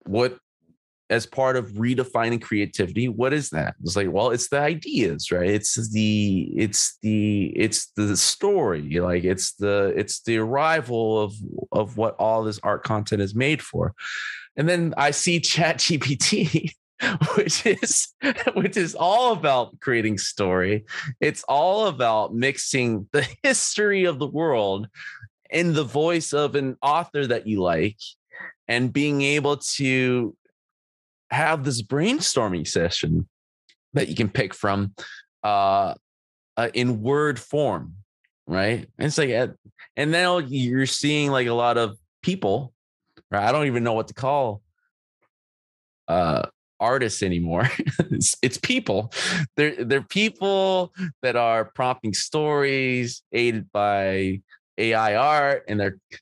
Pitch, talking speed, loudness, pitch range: 125 Hz, 140 wpm, -23 LUFS, 105-150 Hz